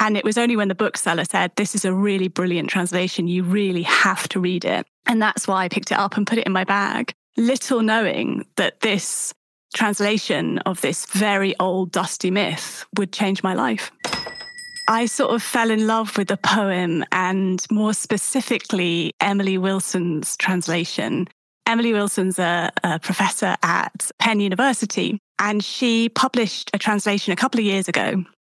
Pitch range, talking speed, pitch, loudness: 185-220 Hz, 170 wpm, 205 Hz, -21 LUFS